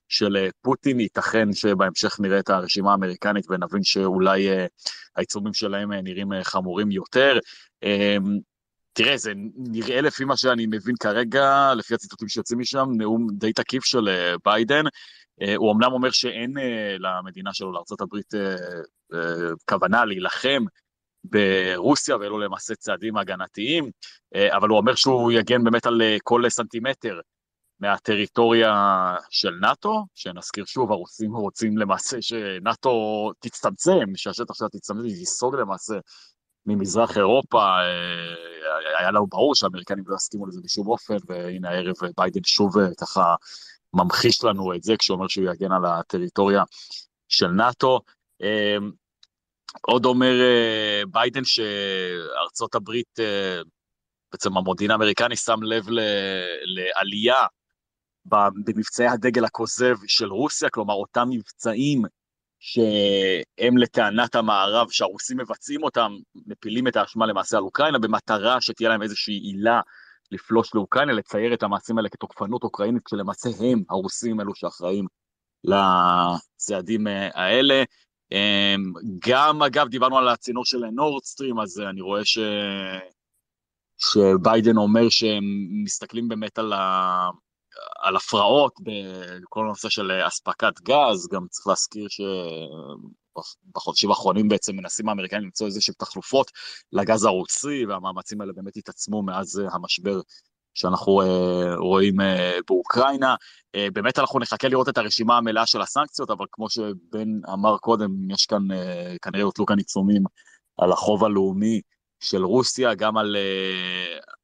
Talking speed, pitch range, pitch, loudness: 125 wpm, 95-115 Hz, 105 Hz, -22 LUFS